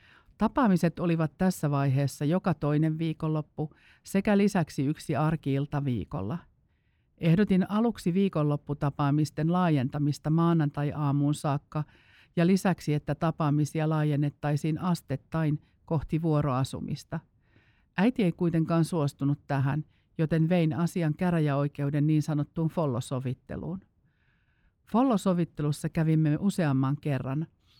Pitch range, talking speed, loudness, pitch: 145-170 Hz, 90 wpm, -28 LUFS, 155 Hz